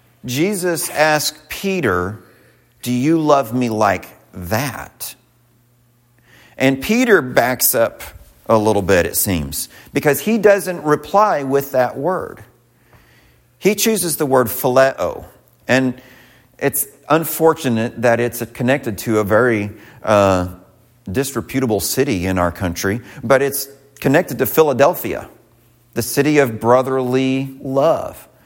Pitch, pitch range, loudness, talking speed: 125 Hz, 115-140 Hz, -17 LUFS, 115 wpm